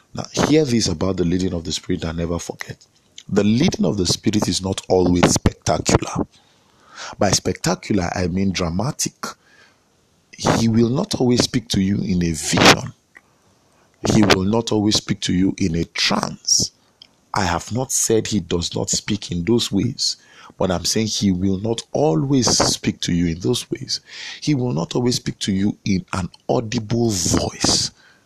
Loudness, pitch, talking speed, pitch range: -19 LUFS, 100 Hz, 170 wpm, 90-115 Hz